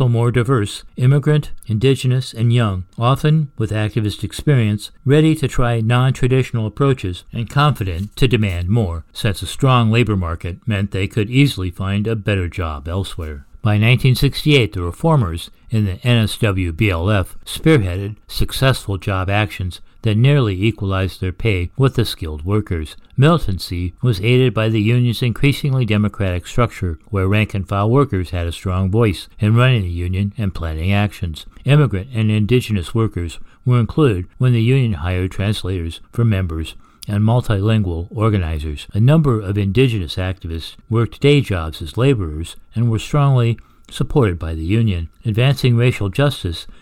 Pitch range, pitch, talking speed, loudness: 95-125 Hz, 105 Hz, 145 wpm, -18 LUFS